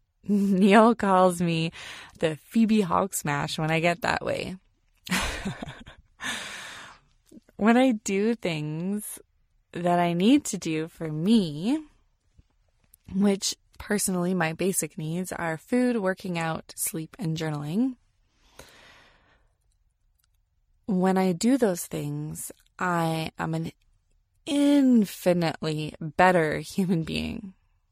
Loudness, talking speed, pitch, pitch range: -25 LUFS, 100 wpm, 175 Hz, 160-205 Hz